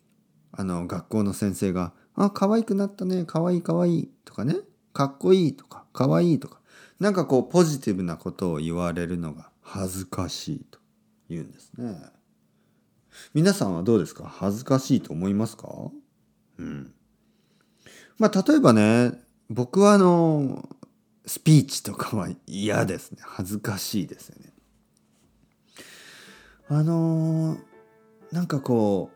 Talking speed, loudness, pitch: 265 characters per minute, -24 LUFS, 140 Hz